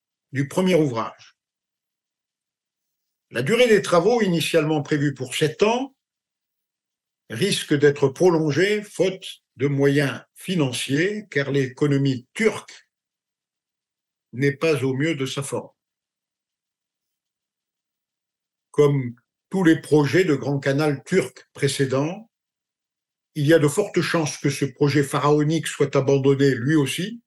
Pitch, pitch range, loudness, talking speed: 150 Hz, 140-175 Hz, -21 LUFS, 115 wpm